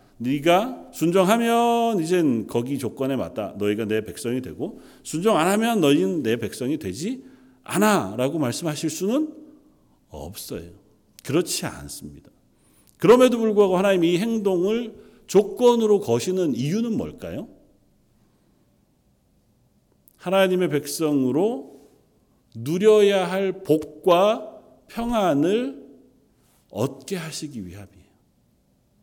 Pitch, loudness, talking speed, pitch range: 185 Hz, -22 LUFS, 230 characters per minute, 140-220 Hz